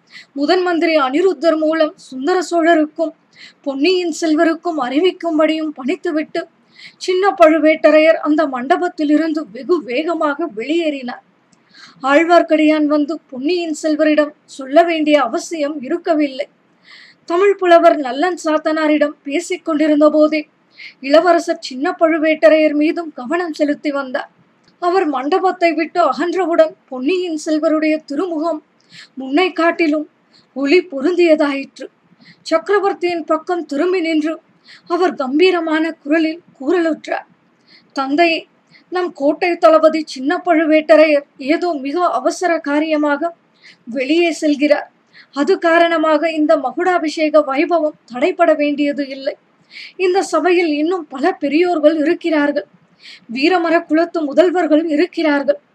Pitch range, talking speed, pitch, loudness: 300-340 Hz, 95 wpm, 320 Hz, -15 LUFS